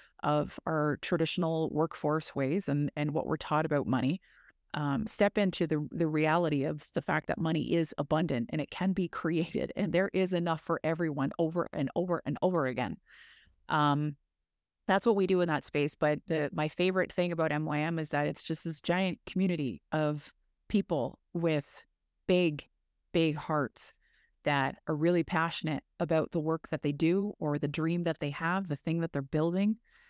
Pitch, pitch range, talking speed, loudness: 160 Hz, 150-175 Hz, 180 wpm, -31 LUFS